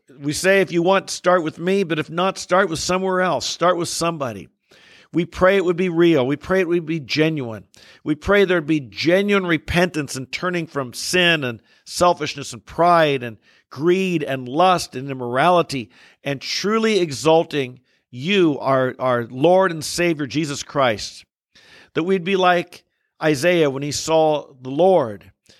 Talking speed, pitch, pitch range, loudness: 165 wpm, 165 Hz, 135-180 Hz, -19 LUFS